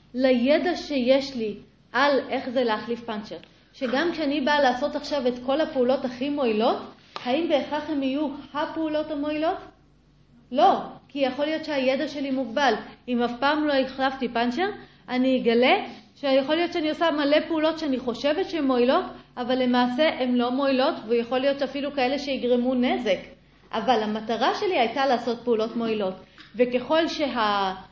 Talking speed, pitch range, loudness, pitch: 150 wpm, 245-295 Hz, -24 LUFS, 265 Hz